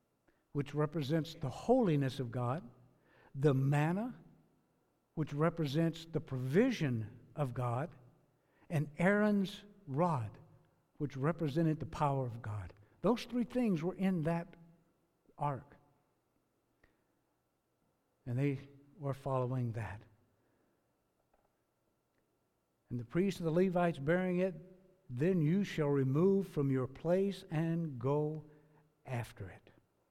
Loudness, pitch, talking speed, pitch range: -36 LUFS, 150 Hz, 110 wpm, 130-170 Hz